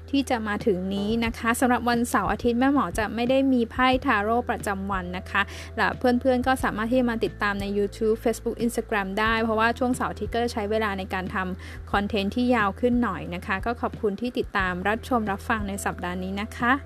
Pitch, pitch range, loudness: 230 Hz, 205-245 Hz, -25 LUFS